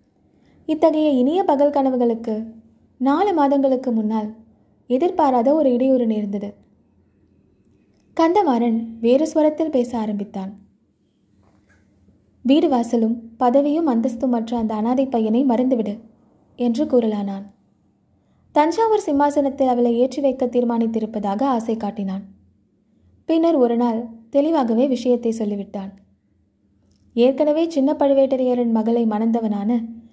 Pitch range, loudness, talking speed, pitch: 210-275 Hz, -19 LUFS, 90 wpm, 235 Hz